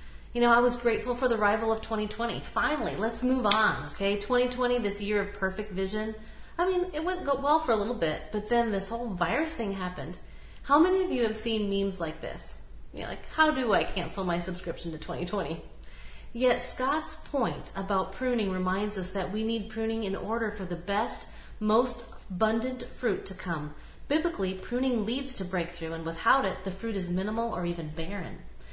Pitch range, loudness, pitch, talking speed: 190-240 Hz, -29 LUFS, 215 Hz, 195 wpm